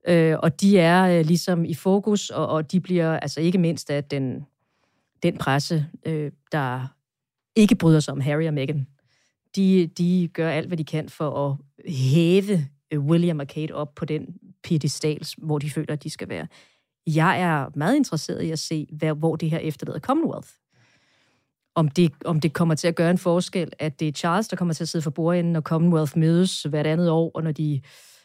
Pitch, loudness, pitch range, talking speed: 160 Hz, -23 LUFS, 150-170 Hz, 200 wpm